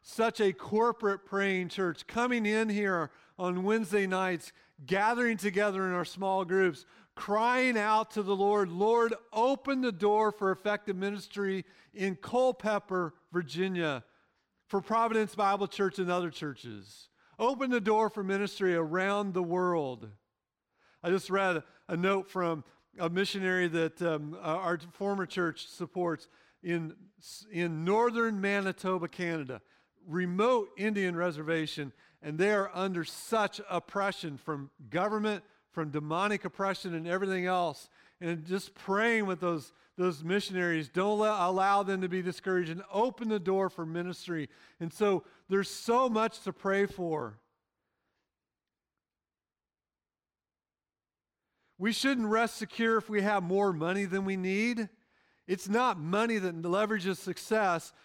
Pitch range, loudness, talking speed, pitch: 170-210 Hz, -31 LUFS, 135 wpm, 190 Hz